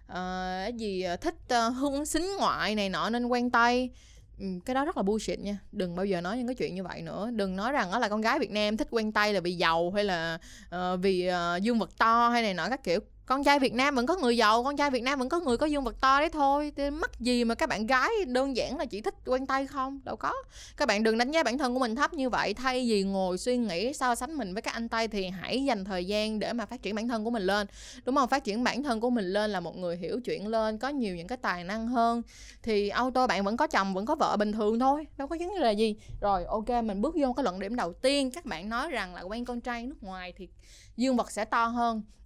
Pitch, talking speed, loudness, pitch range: 235 Hz, 285 wpm, -29 LUFS, 205-260 Hz